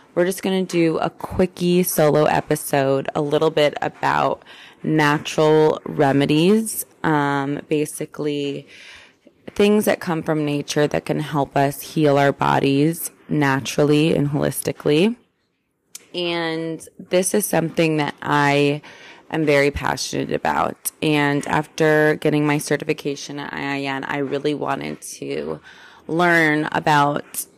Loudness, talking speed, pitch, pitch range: -20 LUFS, 120 wpm, 150 Hz, 145-165 Hz